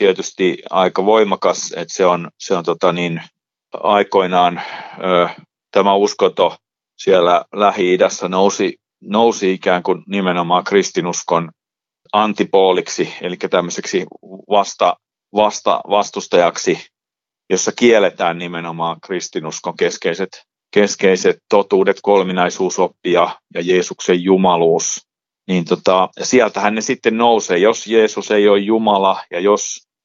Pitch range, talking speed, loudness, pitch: 90-105 Hz, 105 wpm, -16 LUFS, 95 Hz